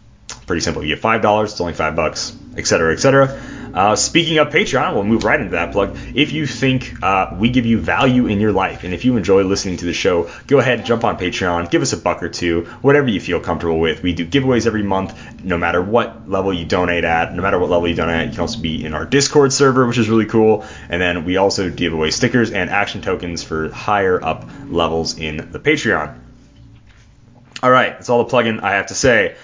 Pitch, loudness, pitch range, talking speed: 105 Hz, -16 LUFS, 85-125 Hz, 245 wpm